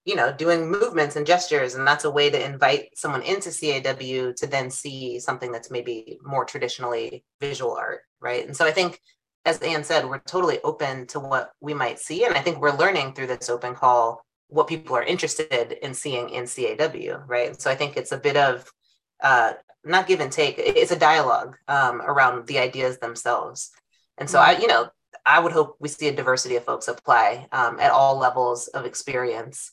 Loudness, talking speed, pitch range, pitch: -22 LUFS, 205 wpm, 125-175 Hz, 145 Hz